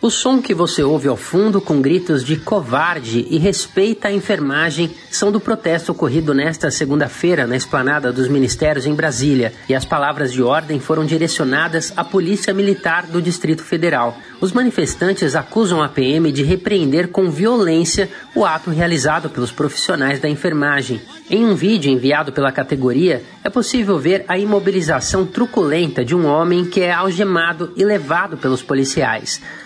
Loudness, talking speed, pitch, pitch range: -16 LUFS, 160 wpm, 165 Hz, 145-190 Hz